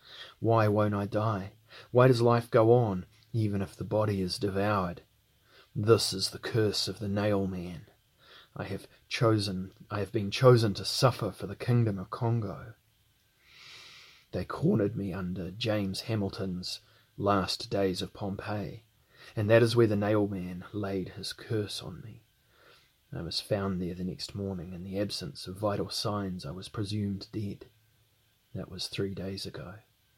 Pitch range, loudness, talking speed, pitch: 95-110 Hz, -30 LUFS, 160 wpm, 105 Hz